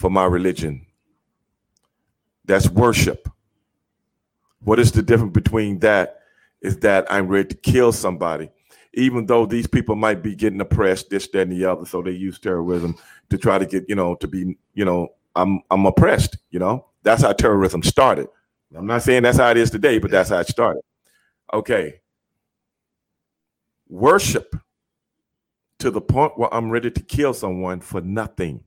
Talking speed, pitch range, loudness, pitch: 165 wpm, 90-115 Hz, -19 LUFS, 100 Hz